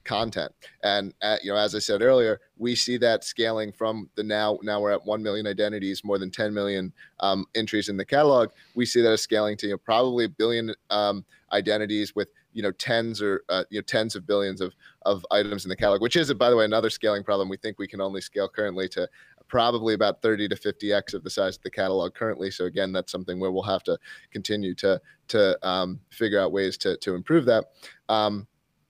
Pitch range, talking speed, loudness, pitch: 100-110 Hz, 230 wpm, -25 LUFS, 105 Hz